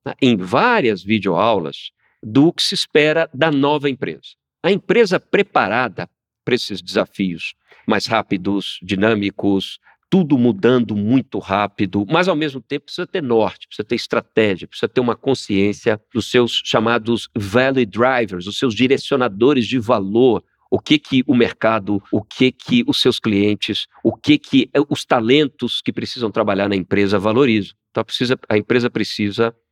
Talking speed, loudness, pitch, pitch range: 150 wpm, -18 LUFS, 115 Hz, 105-135 Hz